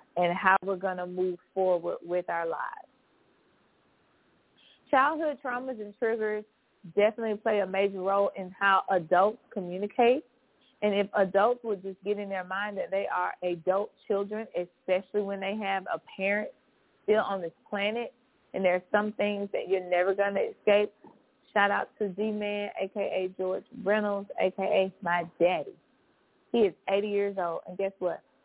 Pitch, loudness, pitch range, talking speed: 200 Hz, -29 LUFS, 190-215 Hz, 160 wpm